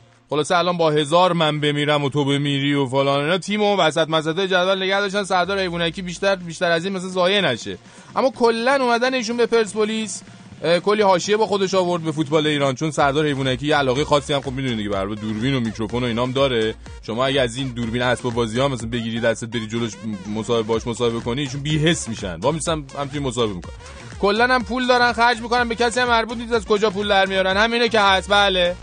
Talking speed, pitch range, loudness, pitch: 220 wpm, 125-200 Hz, -20 LUFS, 160 Hz